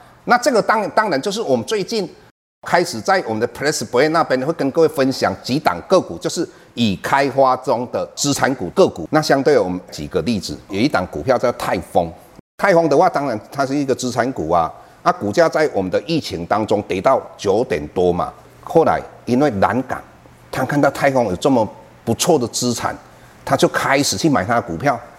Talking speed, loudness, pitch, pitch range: 305 characters per minute, -18 LUFS, 130 Hz, 120-140 Hz